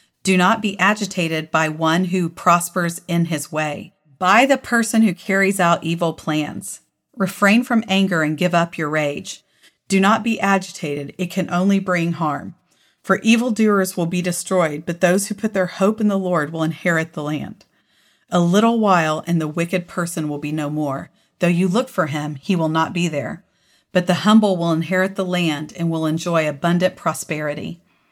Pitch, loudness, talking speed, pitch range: 175 Hz, -19 LUFS, 185 wpm, 160-195 Hz